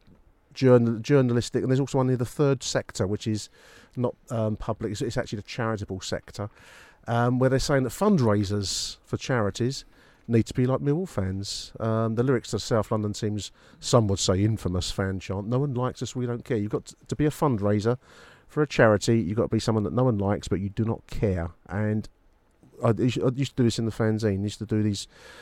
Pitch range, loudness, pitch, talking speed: 105-125 Hz, -26 LUFS, 115 Hz, 220 wpm